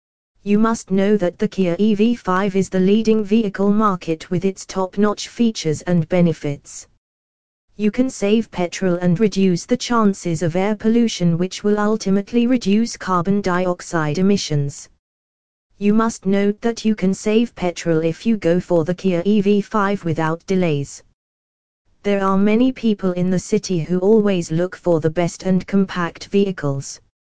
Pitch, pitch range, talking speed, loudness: 190 Hz, 170-210 Hz, 155 wpm, -19 LUFS